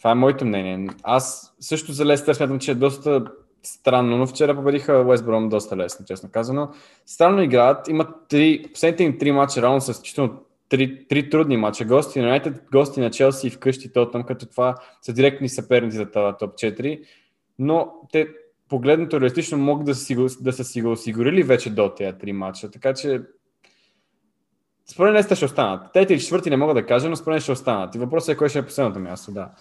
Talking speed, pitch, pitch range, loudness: 205 wpm, 135 Hz, 120-150 Hz, -20 LUFS